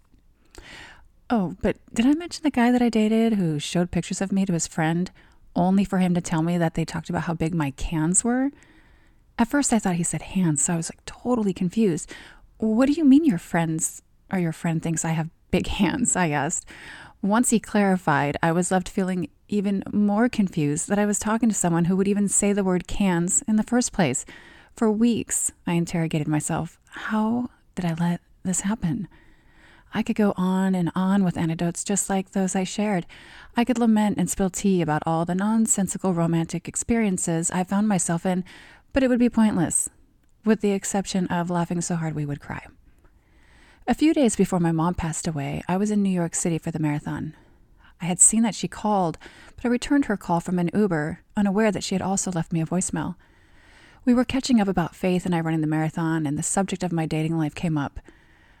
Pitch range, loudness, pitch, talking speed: 165-210 Hz, -23 LUFS, 185 Hz, 210 wpm